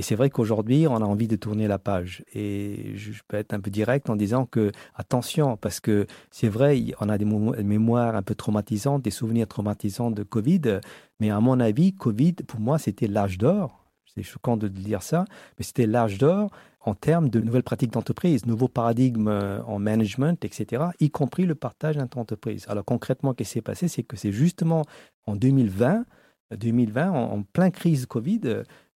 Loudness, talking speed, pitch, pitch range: -25 LUFS, 190 wpm, 115 Hz, 105-140 Hz